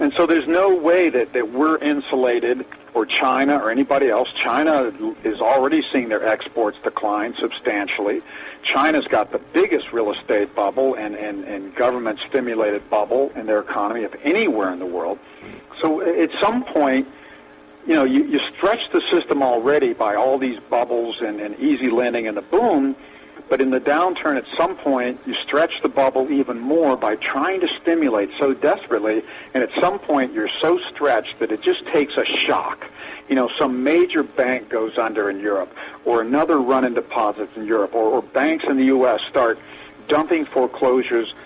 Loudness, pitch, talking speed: -20 LUFS, 135 Hz, 180 wpm